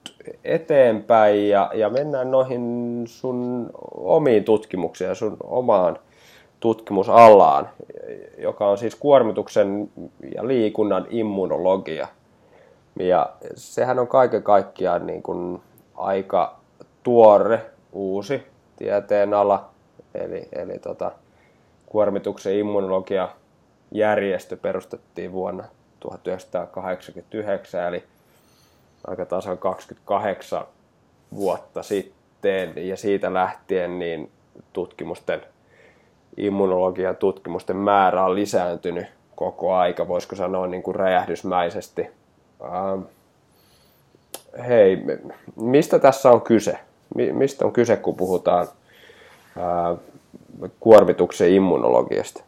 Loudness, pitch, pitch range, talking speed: -21 LUFS, 105 Hz, 95-125 Hz, 85 wpm